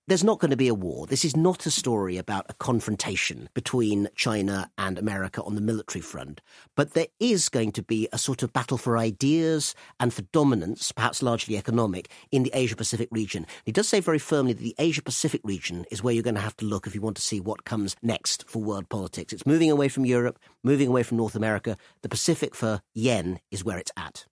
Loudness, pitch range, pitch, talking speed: -26 LUFS, 105-135 Hz, 115 Hz, 230 wpm